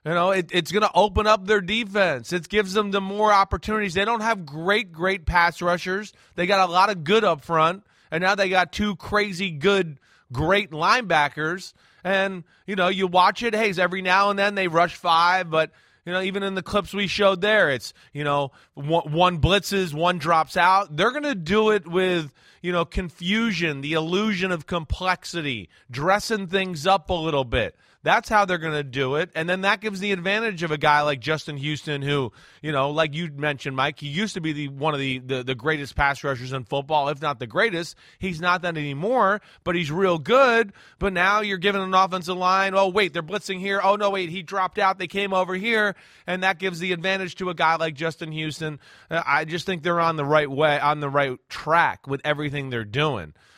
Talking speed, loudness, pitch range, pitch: 215 wpm, -22 LUFS, 155-195 Hz, 180 Hz